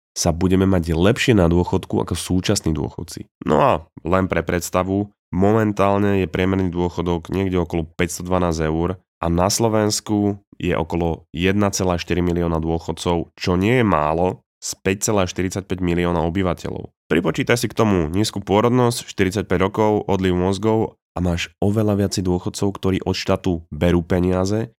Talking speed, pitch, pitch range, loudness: 140 wpm, 95 Hz, 85-100 Hz, -20 LUFS